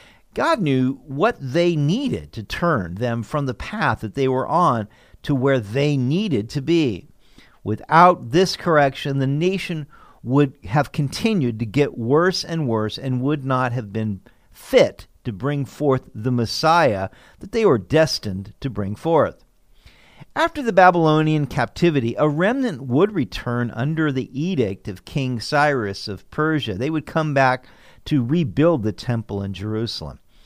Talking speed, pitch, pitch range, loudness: 155 wpm, 135 Hz, 115-155 Hz, -20 LUFS